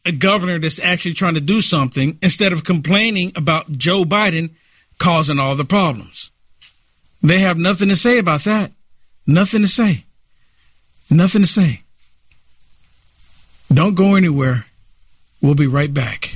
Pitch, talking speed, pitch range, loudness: 160 Hz, 140 wpm, 125-190 Hz, -15 LUFS